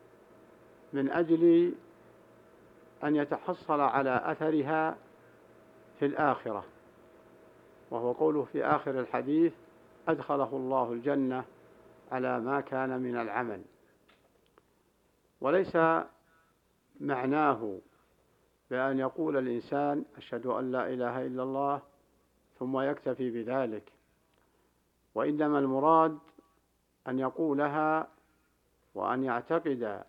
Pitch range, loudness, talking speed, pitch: 130-155 Hz, -31 LUFS, 80 wpm, 140 Hz